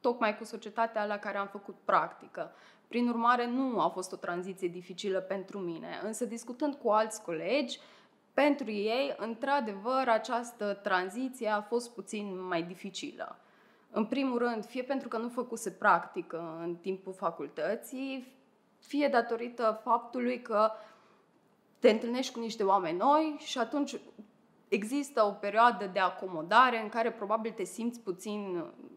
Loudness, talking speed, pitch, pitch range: -32 LUFS, 145 wpm, 220 Hz, 200-245 Hz